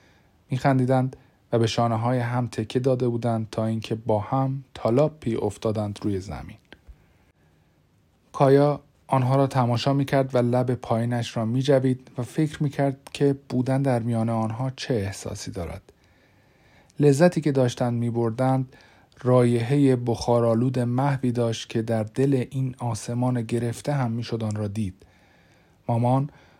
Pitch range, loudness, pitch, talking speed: 115-135 Hz, -24 LUFS, 120 Hz, 130 wpm